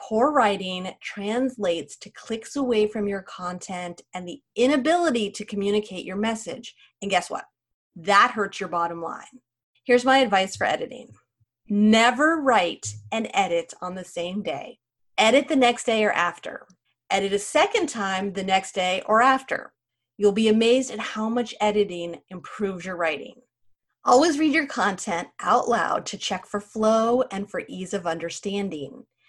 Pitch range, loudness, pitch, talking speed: 180-235 Hz, -23 LUFS, 200 Hz, 160 wpm